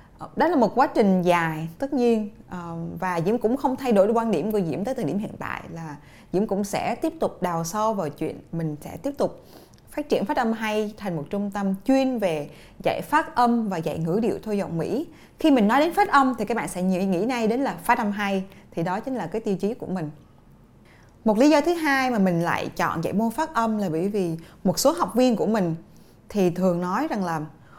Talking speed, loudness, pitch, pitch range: 240 wpm, -24 LUFS, 205 Hz, 175-240 Hz